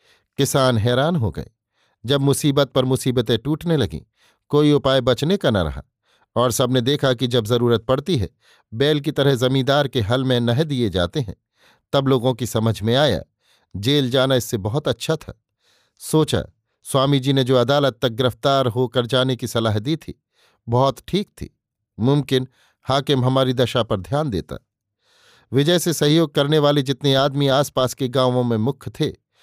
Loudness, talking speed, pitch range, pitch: -19 LUFS, 170 wpm, 120-140 Hz, 130 Hz